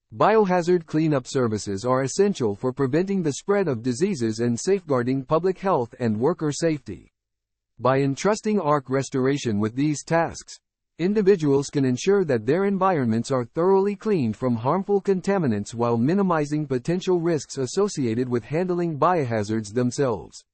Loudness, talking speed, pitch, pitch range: -23 LUFS, 135 wpm, 140 Hz, 125-185 Hz